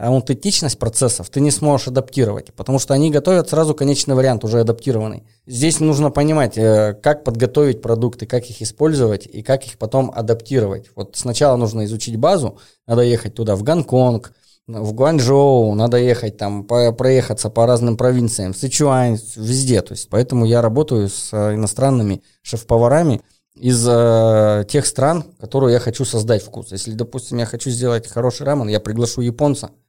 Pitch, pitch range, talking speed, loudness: 120 Hz, 110-135 Hz, 155 wpm, -17 LUFS